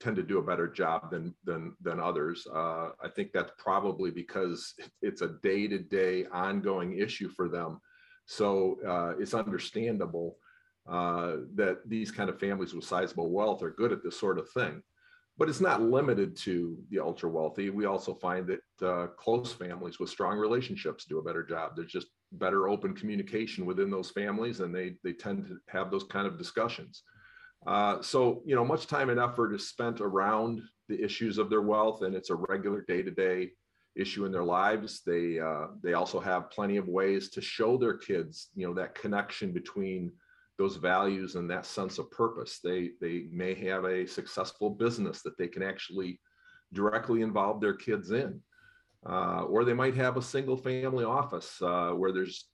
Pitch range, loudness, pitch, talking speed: 90-125 Hz, -32 LUFS, 100 Hz, 185 wpm